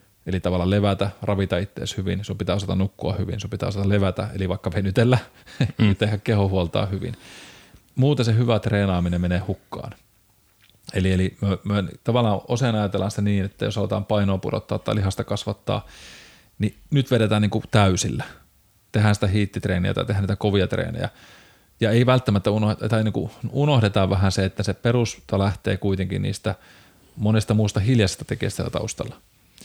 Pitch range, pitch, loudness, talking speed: 95-110 Hz, 105 Hz, -23 LUFS, 155 wpm